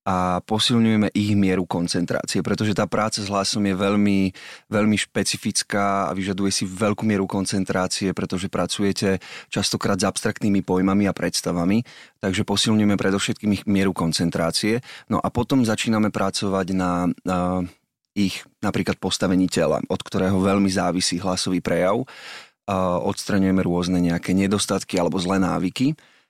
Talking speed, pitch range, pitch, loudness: 130 wpm, 90-105 Hz, 95 Hz, -22 LUFS